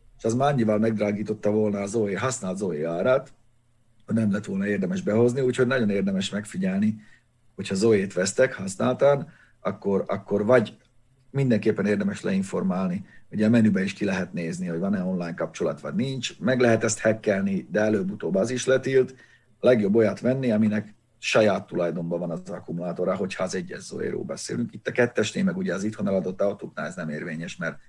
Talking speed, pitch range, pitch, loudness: 175 wpm, 100-130 Hz, 115 Hz, -25 LUFS